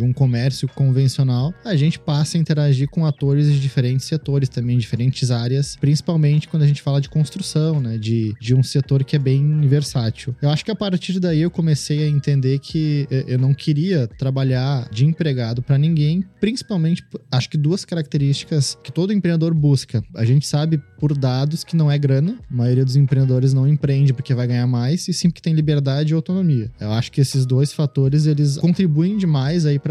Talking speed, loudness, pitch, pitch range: 195 wpm, -19 LUFS, 145 Hz, 130-155 Hz